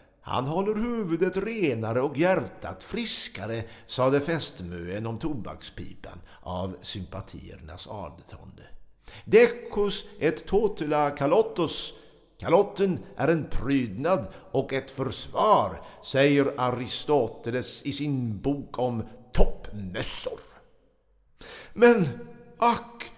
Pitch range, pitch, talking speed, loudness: 110-190 Hz, 135 Hz, 90 wpm, -27 LUFS